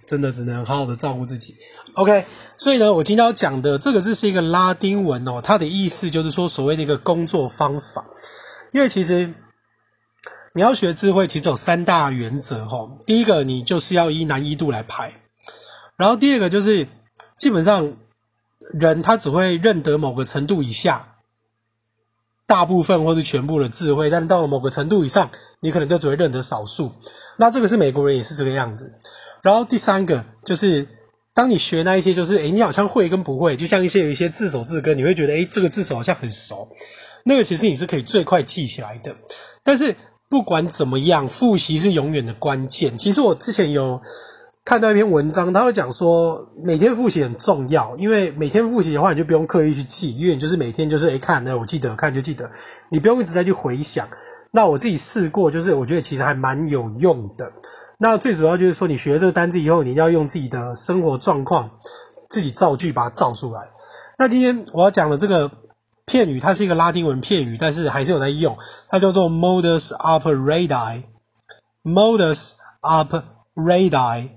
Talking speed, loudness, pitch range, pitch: 320 characters per minute, -17 LUFS, 140-195 Hz, 165 Hz